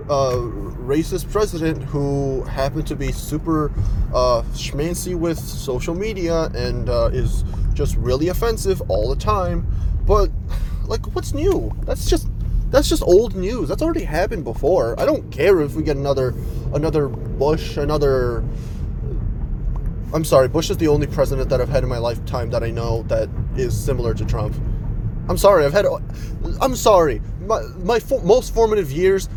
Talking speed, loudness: 160 wpm, -20 LUFS